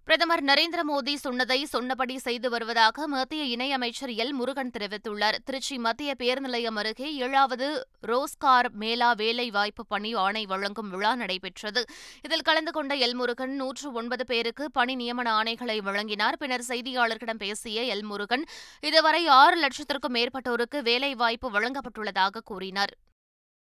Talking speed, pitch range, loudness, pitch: 125 wpm, 225-275 Hz, -26 LUFS, 245 Hz